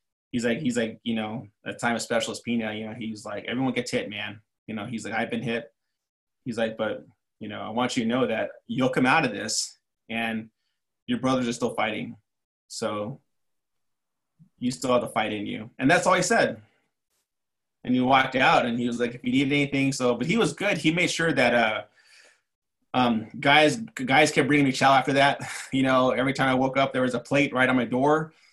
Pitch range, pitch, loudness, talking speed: 115-140 Hz, 125 Hz, -24 LUFS, 225 wpm